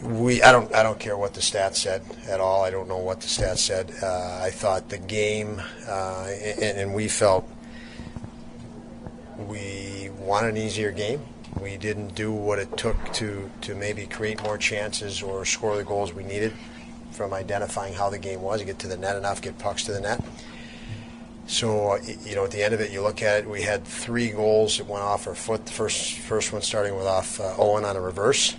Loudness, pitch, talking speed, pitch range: -25 LUFS, 105 Hz, 215 wpm, 100-110 Hz